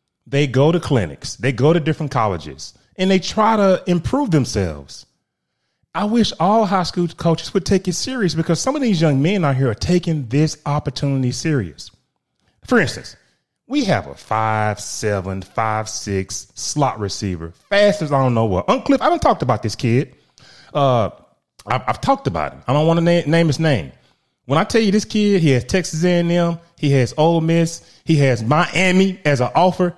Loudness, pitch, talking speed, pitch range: -18 LUFS, 155 Hz, 185 wpm, 125-180 Hz